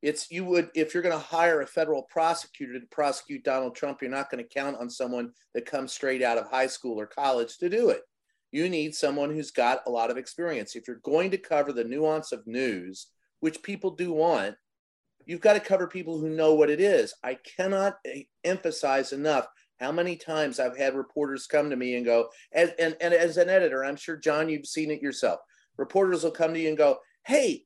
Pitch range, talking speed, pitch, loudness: 135-175 Hz, 220 wpm, 155 Hz, -27 LUFS